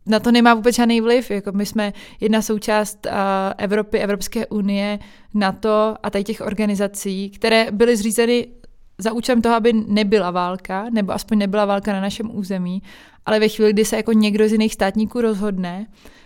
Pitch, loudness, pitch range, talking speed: 215 Hz, -19 LUFS, 200-225 Hz, 170 wpm